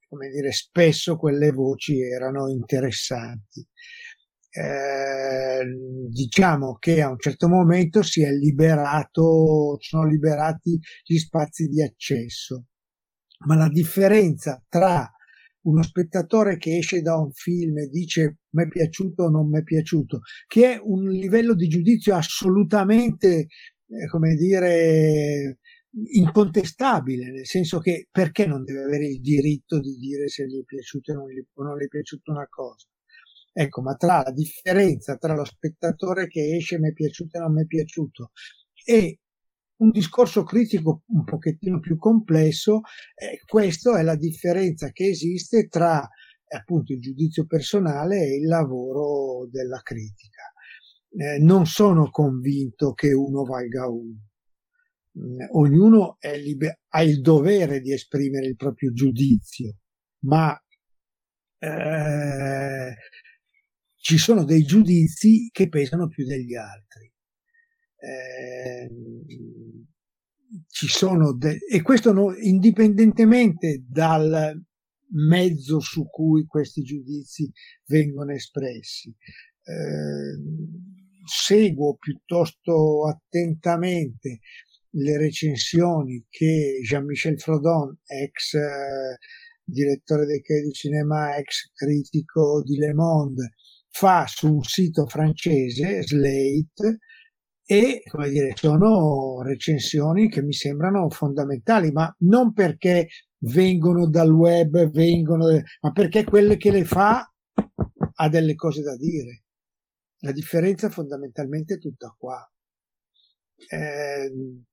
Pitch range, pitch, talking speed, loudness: 140-180 Hz, 155 Hz, 120 wpm, -21 LUFS